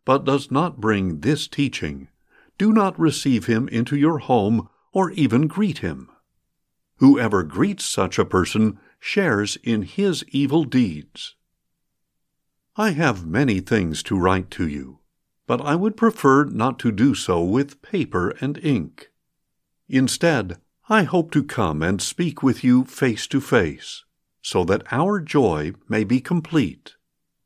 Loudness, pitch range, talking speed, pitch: -21 LUFS, 105-155 Hz, 145 wpm, 135 Hz